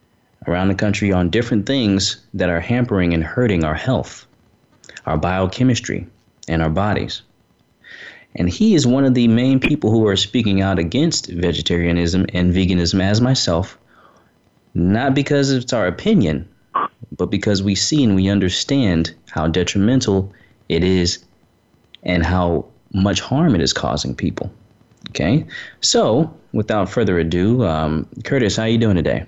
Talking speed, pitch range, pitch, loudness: 150 wpm, 90-115 Hz, 95 Hz, -18 LUFS